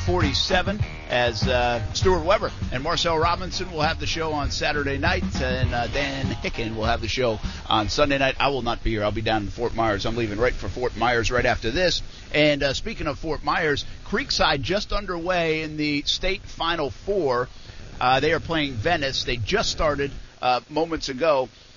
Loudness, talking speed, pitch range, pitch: -23 LUFS, 195 wpm, 105-150 Hz, 125 Hz